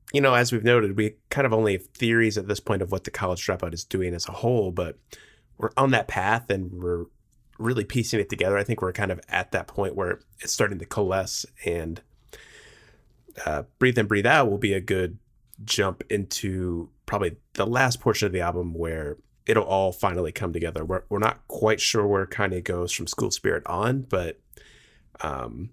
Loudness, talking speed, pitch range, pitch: -25 LUFS, 210 wpm, 90-115 Hz, 100 Hz